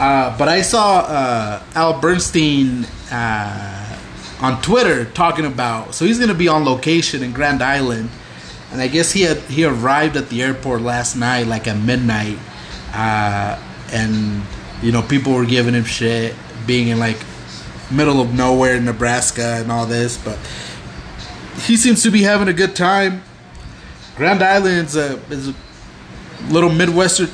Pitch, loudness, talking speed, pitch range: 125 Hz, -16 LUFS, 160 wpm, 115-160 Hz